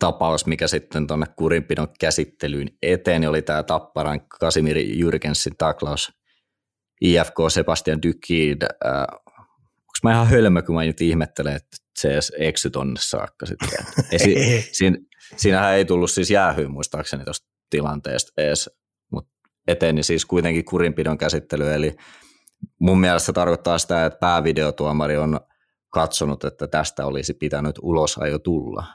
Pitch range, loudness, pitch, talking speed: 75-85 Hz, -21 LUFS, 80 Hz, 145 wpm